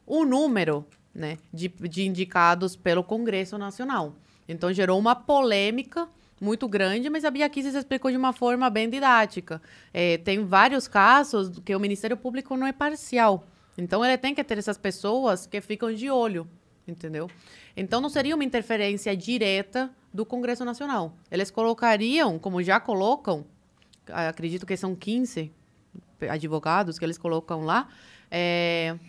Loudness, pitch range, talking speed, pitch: -25 LUFS, 175-245 Hz, 145 wpm, 205 Hz